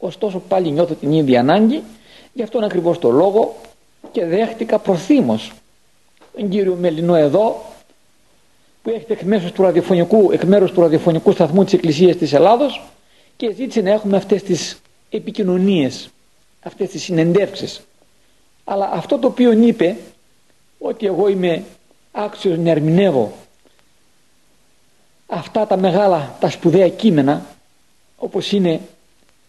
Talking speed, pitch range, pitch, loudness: 125 wpm, 170-215 Hz, 190 Hz, -16 LUFS